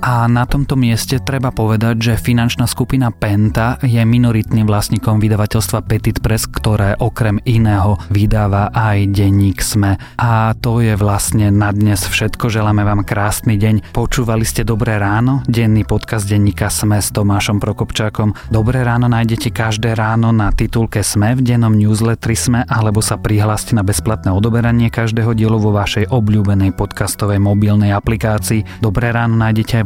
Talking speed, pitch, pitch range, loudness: 150 wpm, 110 Hz, 105-115 Hz, -14 LUFS